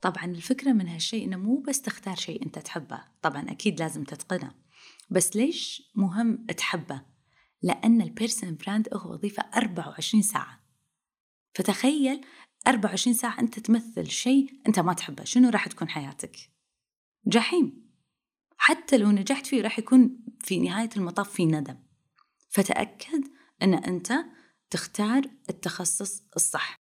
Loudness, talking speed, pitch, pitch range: -26 LUFS, 125 wpm, 215 Hz, 185-255 Hz